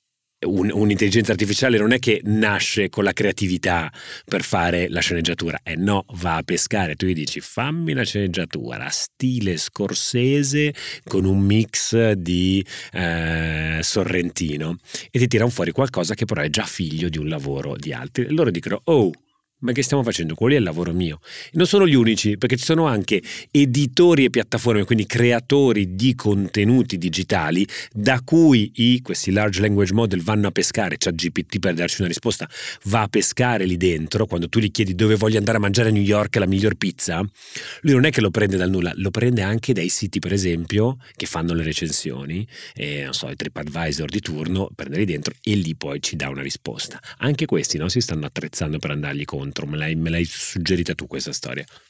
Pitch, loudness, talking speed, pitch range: 100 Hz, -20 LUFS, 195 wpm, 85-115 Hz